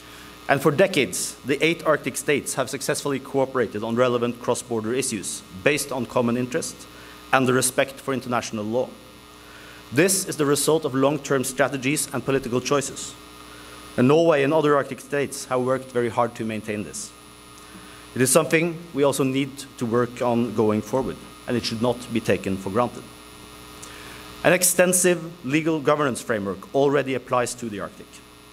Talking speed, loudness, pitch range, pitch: 160 wpm, -23 LUFS, 115-140 Hz, 130 Hz